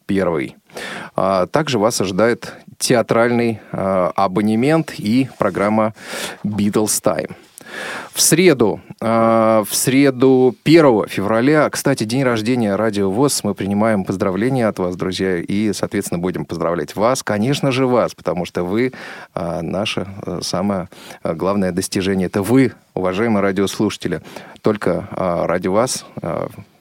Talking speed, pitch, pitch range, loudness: 125 wpm, 110 Hz, 100-125 Hz, -17 LUFS